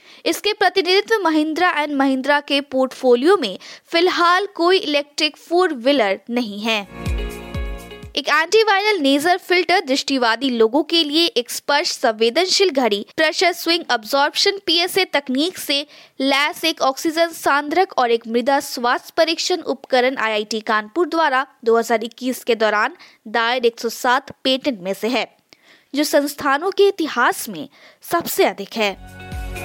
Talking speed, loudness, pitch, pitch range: 125 wpm, -18 LUFS, 290 Hz, 245-345 Hz